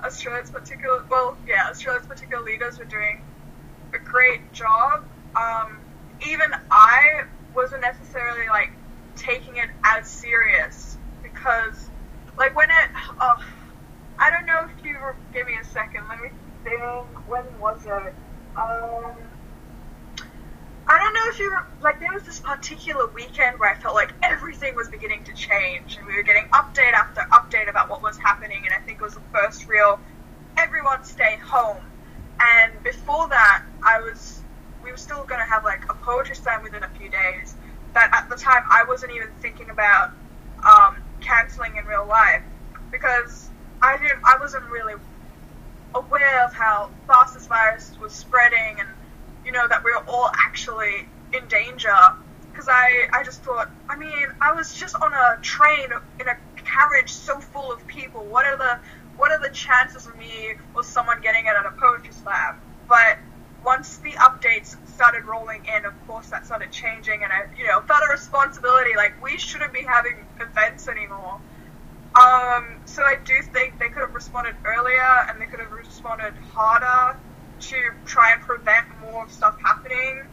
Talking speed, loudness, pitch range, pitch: 170 wpm, -19 LUFS, 230-290 Hz, 250 Hz